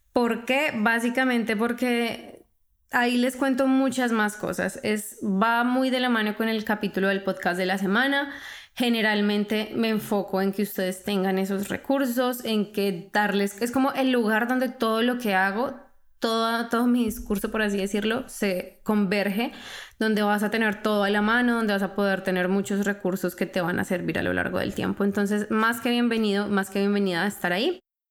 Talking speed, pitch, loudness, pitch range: 190 wpm, 215 Hz, -25 LUFS, 200-240 Hz